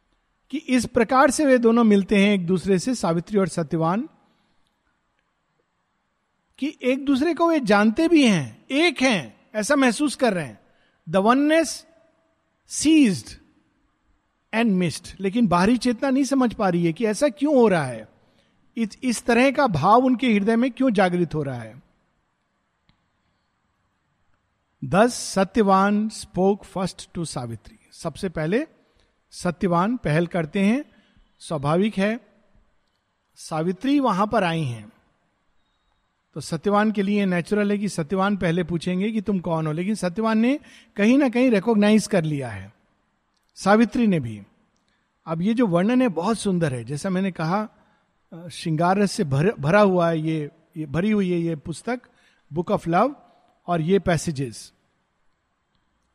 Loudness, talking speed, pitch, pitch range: -21 LUFS, 145 wpm, 205 Hz, 170-240 Hz